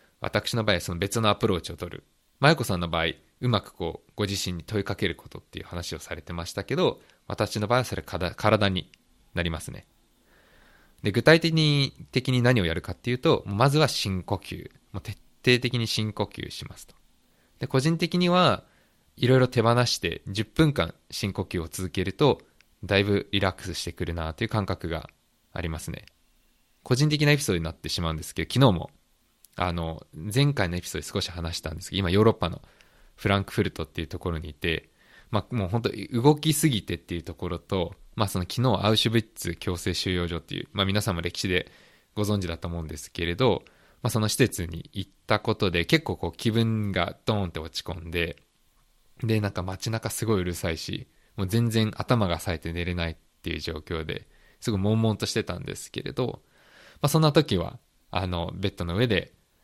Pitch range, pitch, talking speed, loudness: 85-115 Hz, 100 Hz, 385 characters per minute, -26 LUFS